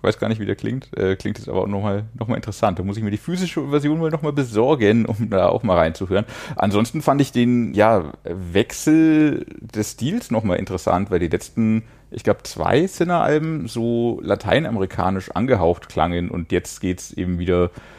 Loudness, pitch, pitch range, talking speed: -20 LUFS, 110 Hz, 95-130 Hz, 190 wpm